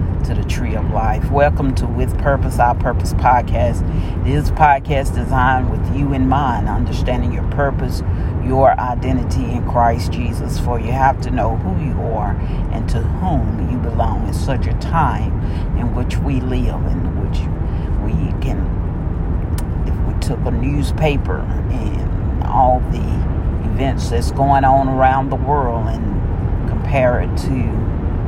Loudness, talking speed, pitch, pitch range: -18 LUFS, 155 wpm, 90 Hz, 85-120 Hz